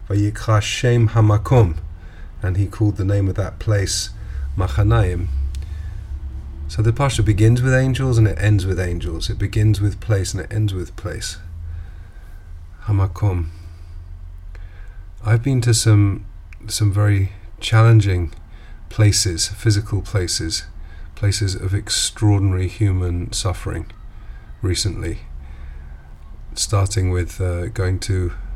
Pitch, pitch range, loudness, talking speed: 95 Hz, 85-105 Hz, -19 LUFS, 110 wpm